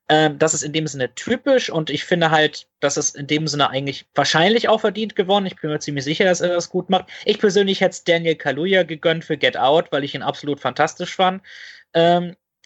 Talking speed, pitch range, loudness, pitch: 230 wpm, 150-185 Hz, -19 LUFS, 165 Hz